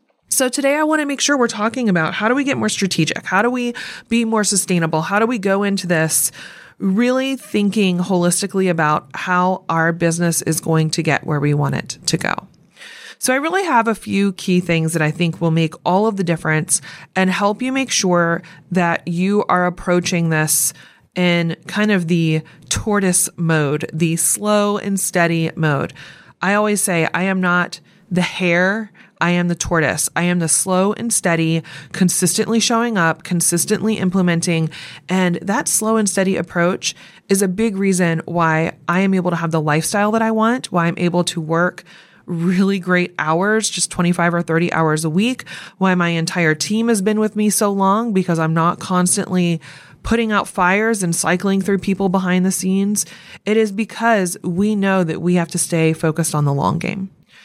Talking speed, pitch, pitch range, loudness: 190 wpm, 180 Hz, 170-205 Hz, -17 LUFS